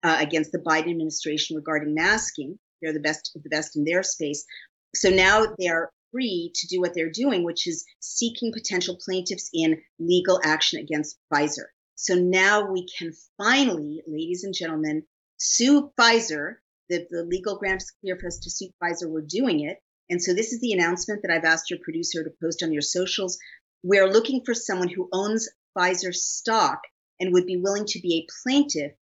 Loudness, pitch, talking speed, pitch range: -24 LUFS, 180 Hz, 190 wpm, 160-195 Hz